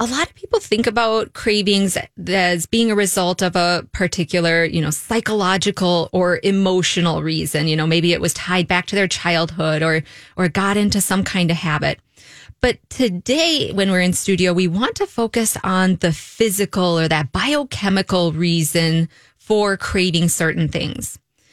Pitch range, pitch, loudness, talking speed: 165-200 Hz, 180 Hz, -18 LUFS, 165 wpm